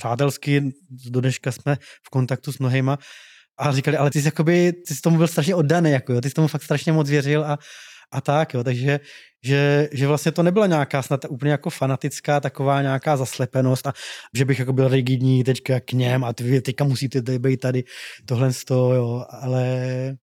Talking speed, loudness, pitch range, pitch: 200 wpm, -21 LUFS, 130-145 Hz, 135 Hz